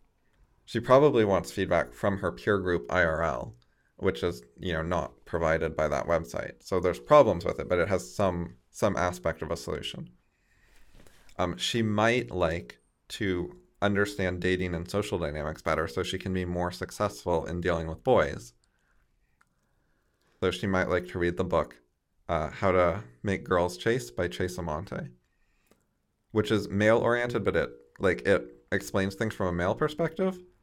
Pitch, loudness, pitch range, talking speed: 90 Hz, -28 LUFS, 80-100 Hz, 165 wpm